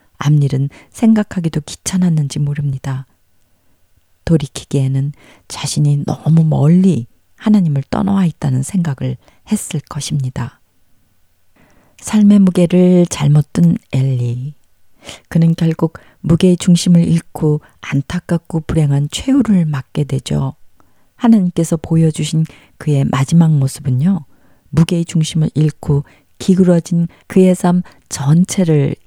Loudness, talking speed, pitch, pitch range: -15 LUFS, 250 characters per minute, 155 Hz, 135-175 Hz